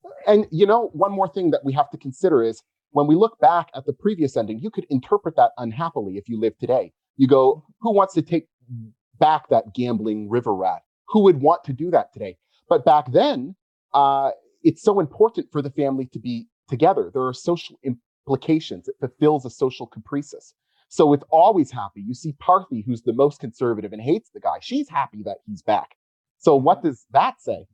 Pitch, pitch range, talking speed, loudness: 145 Hz, 125-195 Hz, 205 wpm, -21 LUFS